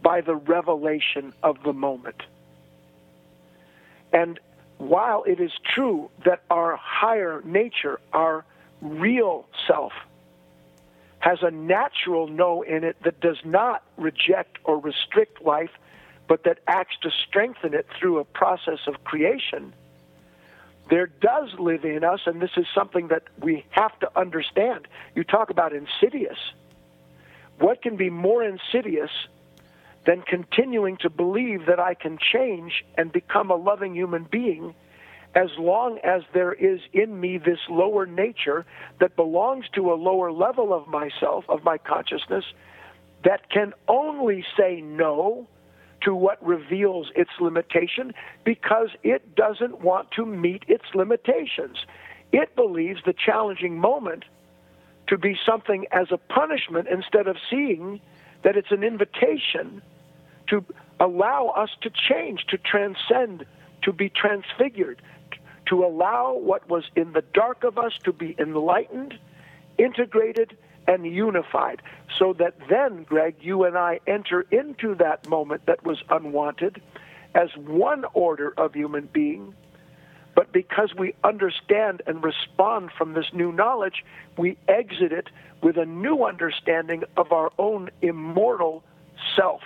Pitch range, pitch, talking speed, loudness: 165-205 Hz, 180 Hz, 135 wpm, -23 LUFS